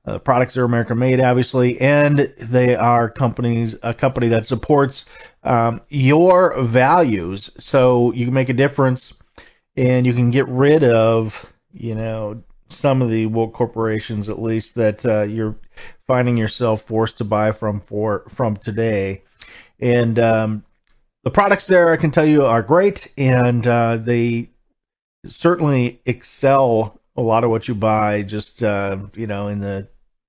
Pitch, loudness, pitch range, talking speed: 120 Hz, -17 LUFS, 110-130 Hz, 155 wpm